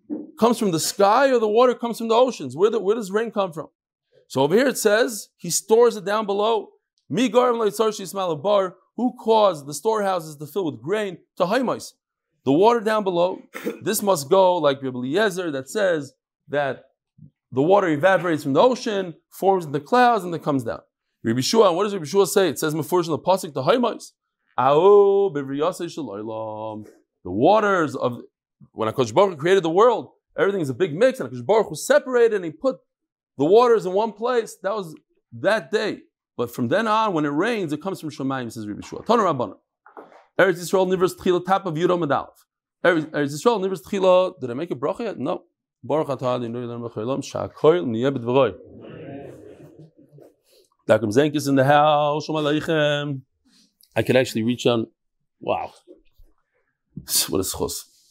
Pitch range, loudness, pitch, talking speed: 145-220 Hz, -21 LUFS, 185 Hz, 170 wpm